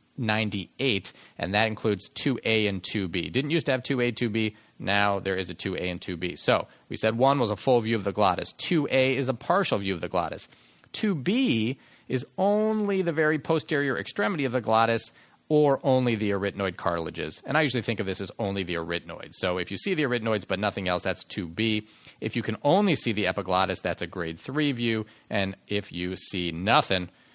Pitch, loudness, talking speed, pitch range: 110 Hz, -27 LUFS, 200 wpm, 95-130 Hz